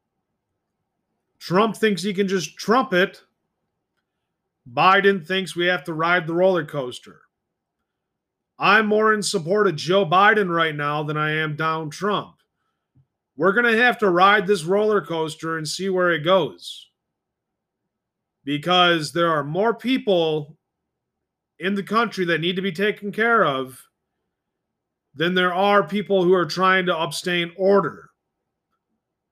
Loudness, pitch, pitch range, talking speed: -20 LUFS, 185 Hz, 165-200 Hz, 140 wpm